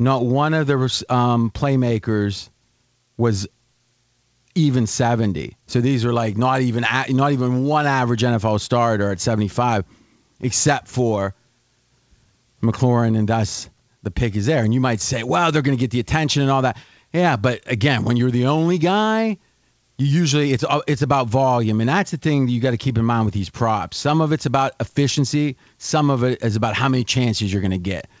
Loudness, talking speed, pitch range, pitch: -19 LUFS, 195 wpm, 115-140 Hz, 125 Hz